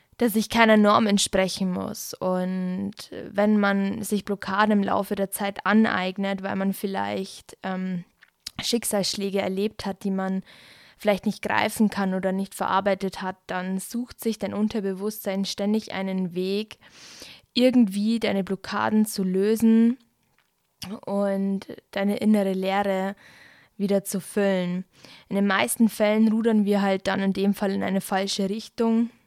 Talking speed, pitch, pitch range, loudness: 140 wpm, 200 Hz, 190-215 Hz, -24 LUFS